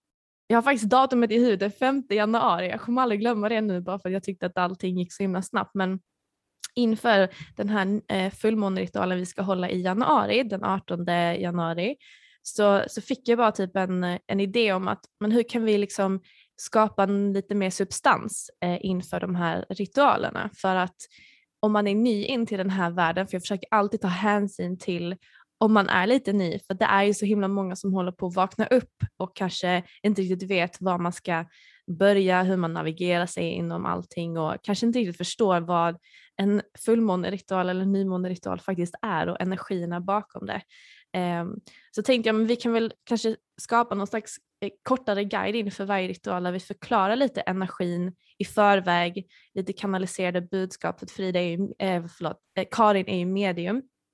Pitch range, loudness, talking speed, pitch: 180-215 Hz, -26 LUFS, 175 wpm, 195 Hz